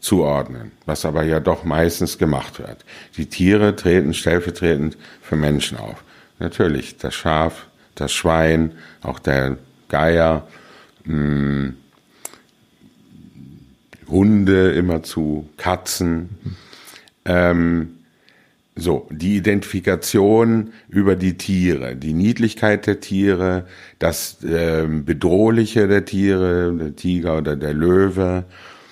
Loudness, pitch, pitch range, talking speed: -19 LUFS, 85 Hz, 80-95 Hz, 95 wpm